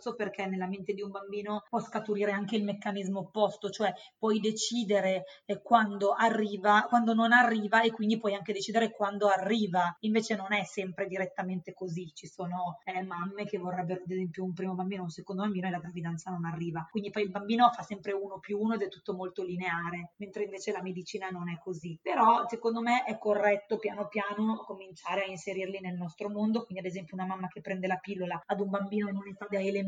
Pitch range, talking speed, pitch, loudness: 185-210 Hz, 205 wpm, 200 Hz, -31 LUFS